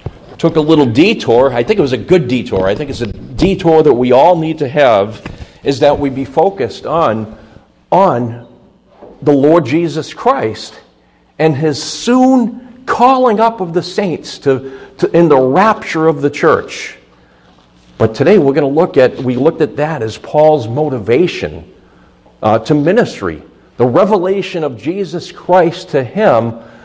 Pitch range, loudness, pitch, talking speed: 120-175 Hz, -12 LUFS, 150 Hz, 165 wpm